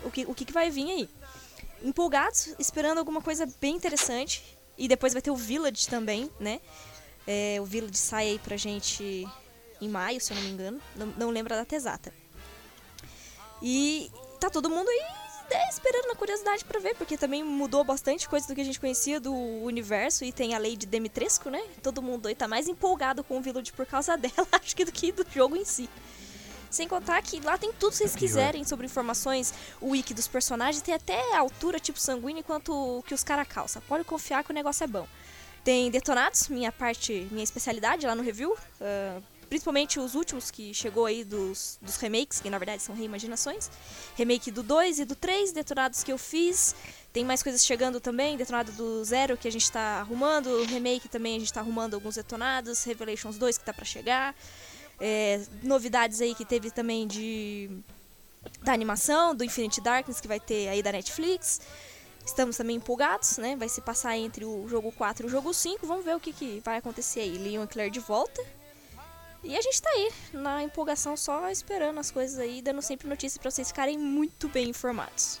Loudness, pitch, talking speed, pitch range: -29 LUFS, 255 Hz, 200 wpm, 230-300 Hz